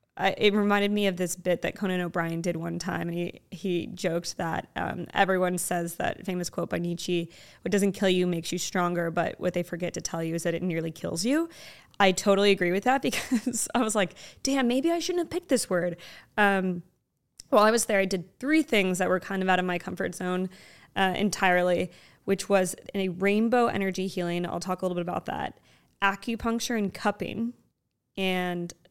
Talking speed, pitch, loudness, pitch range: 210 wpm, 185 Hz, -27 LUFS, 175-205 Hz